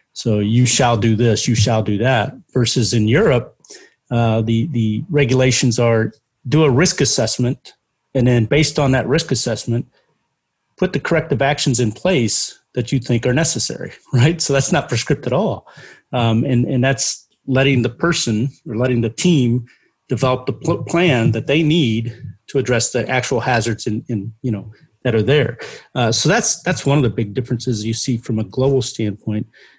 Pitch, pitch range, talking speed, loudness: 125 Hz, 115-135 Hz, 180 wpm, -17 LUFS